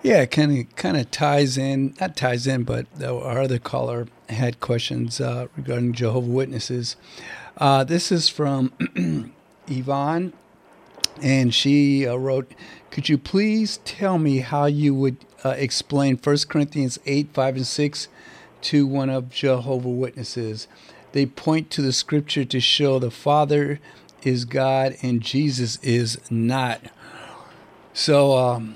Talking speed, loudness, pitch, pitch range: 140 wpm, -22 LUFS, 135 Hz, 125-145 Hz